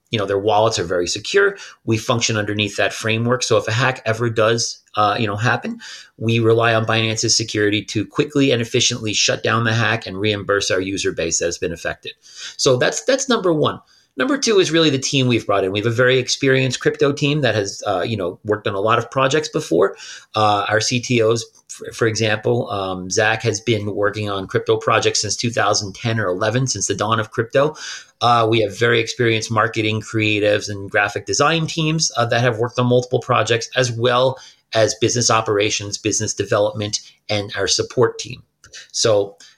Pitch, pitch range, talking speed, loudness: 115 Hz, 105-125 Hz, 195 wpm, -18 LUFS